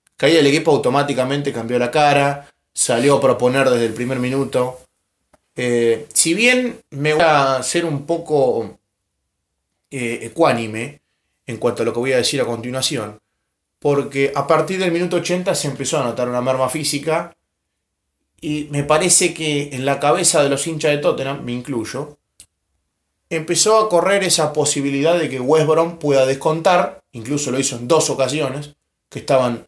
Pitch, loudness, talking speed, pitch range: 140 Hz, -17 LUFS, 165 wpm, 125-155 Hz